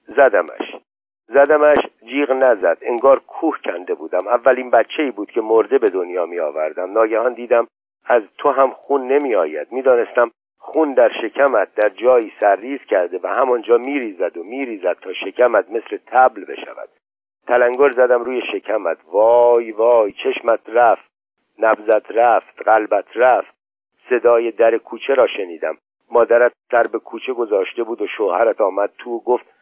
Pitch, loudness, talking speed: 140 Hz, -17 LUFS, 150 wpm